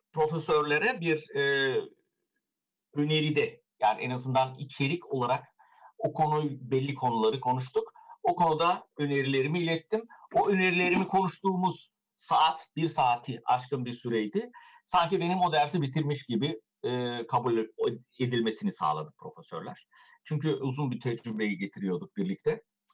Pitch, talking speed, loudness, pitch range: 155 Hz, 115 wpm, -29 LUFS, 130-190 Hz